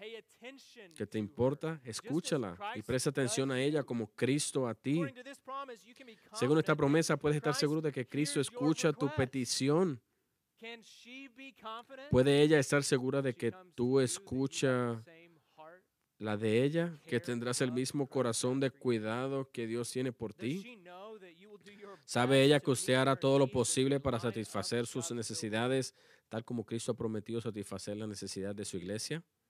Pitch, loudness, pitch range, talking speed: 135 Hz, -33 LUFS, 120-160 Hz, 145 wpm